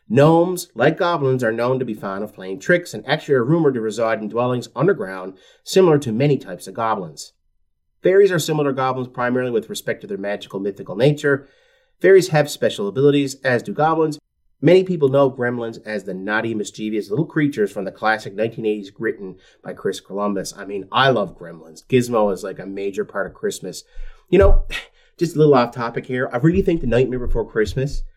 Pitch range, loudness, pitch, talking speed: 105-155 Hz, -19 LUFS, 125 Hz, 195 wpm